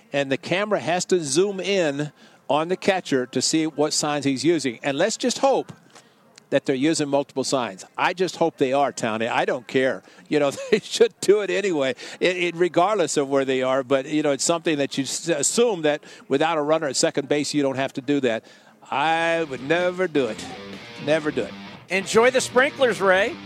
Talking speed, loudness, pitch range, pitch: 210 wpm, -22 LUFS, 140-185 Hz, 150 Hz